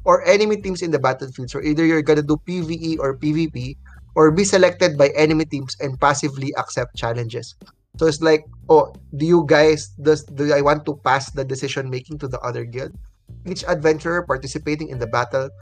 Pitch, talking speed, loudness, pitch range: 145 Hz, 190 wpm, -19 LUFS, 130-160 Hz